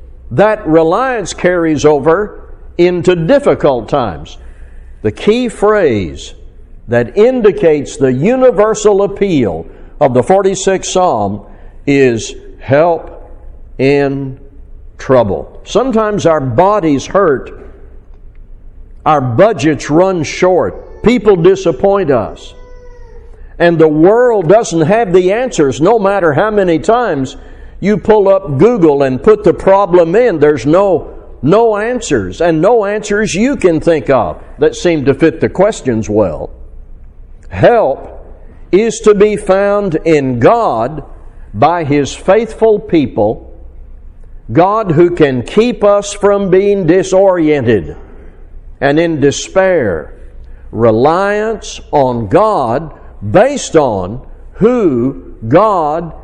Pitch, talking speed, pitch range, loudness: 175 Hz, 110 wpm, 140-205 Hz, -11 LUFS